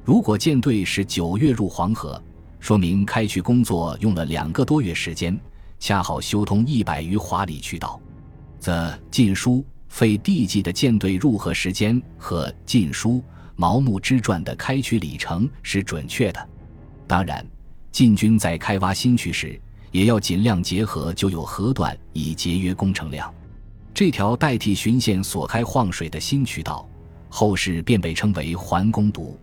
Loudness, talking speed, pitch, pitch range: -21 LUFS, 230 characters per minute, 100 Hz, 85-110 Hz